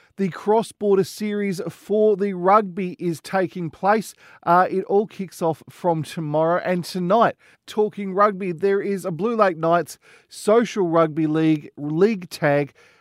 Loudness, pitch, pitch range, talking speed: -21 LUFS, 190 Hz, 165-205 Hz, 150 wpm